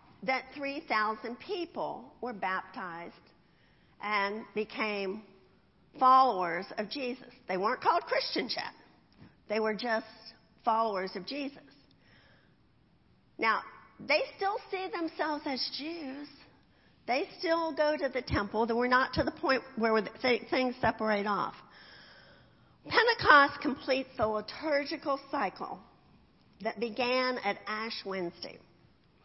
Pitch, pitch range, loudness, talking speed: 250 Hz, 215-290 Hz, -31 LUFS, 110 wpm